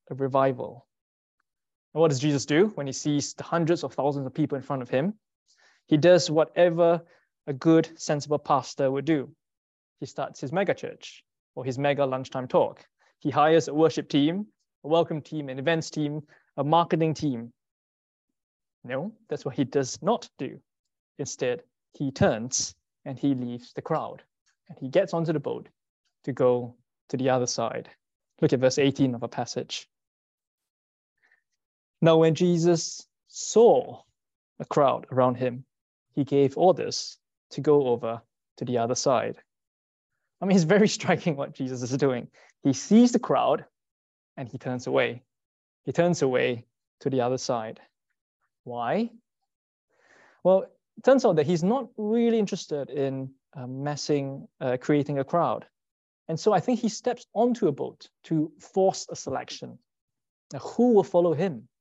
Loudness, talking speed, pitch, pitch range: -26 LUFS, 160 wpm, 145 Hz, 130-175 Hz